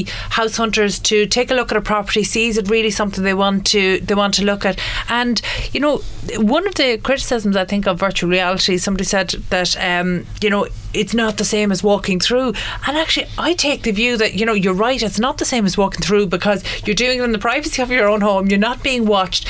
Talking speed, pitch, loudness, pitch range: 245 wpm, 210 Hz, -16 LUFS, 195-235 Hz